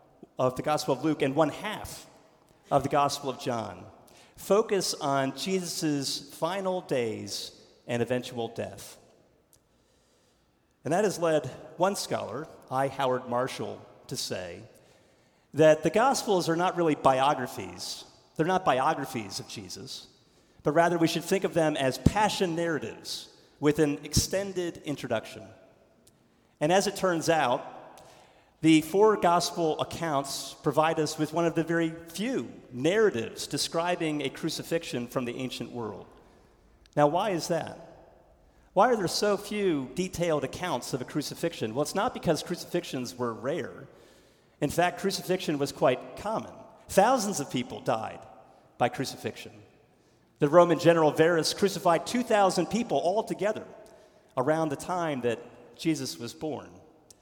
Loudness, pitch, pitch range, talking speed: -28 LUFS, 155 Hz, 135-175 Hz, 135 wpm